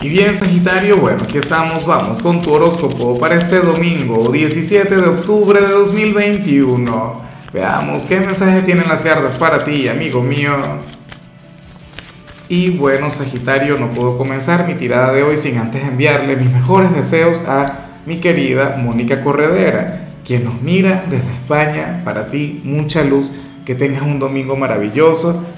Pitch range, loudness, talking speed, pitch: 135-170 Hz, -13 LUFS, 150 wpm, 150 Hz